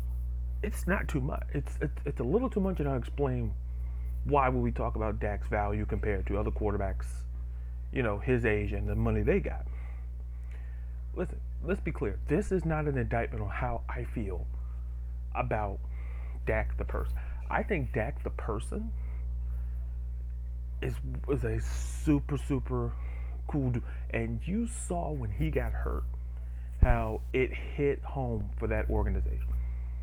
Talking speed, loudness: 155 wpm, -33 LUFS